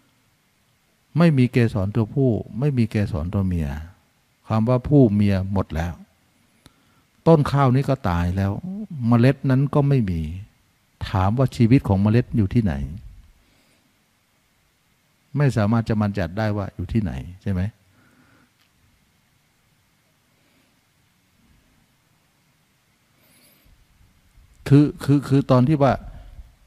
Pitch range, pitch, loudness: 95-135 Hz, 115 Hz, -21 LUFS